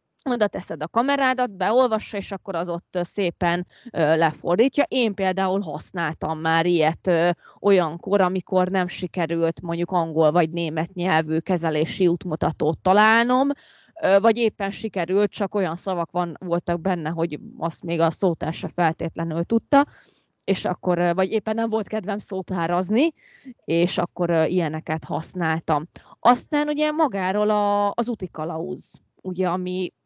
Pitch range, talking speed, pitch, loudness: 165-205 Hz, 140 wpm, 180 Hz, -23 LUFS